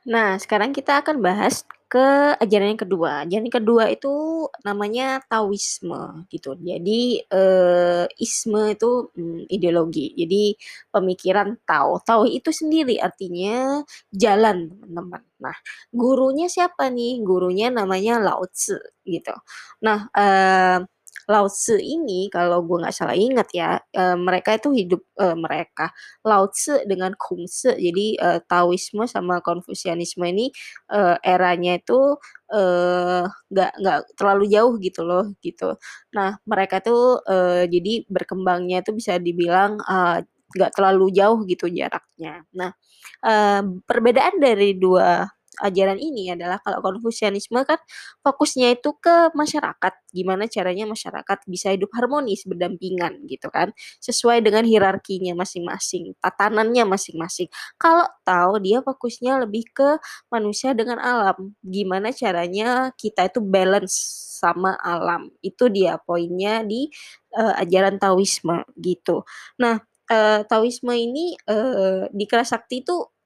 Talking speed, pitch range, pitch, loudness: 125 wpm, 185-240 Hz, 200 Hz, -20 LUFS